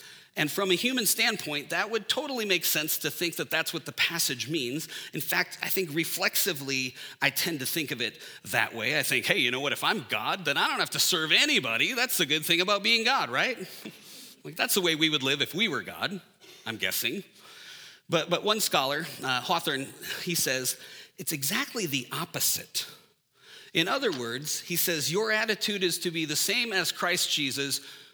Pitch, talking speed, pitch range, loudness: 175 Hz, 205 wpm, 155-210 Hz, -27 LUFS